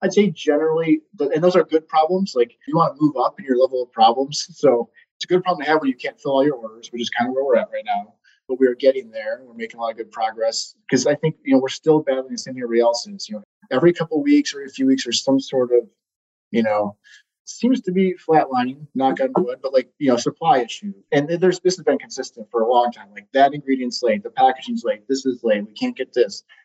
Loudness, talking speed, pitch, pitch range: -20 LUFS, 265 wpm, 150 Hz, 130-200 Hz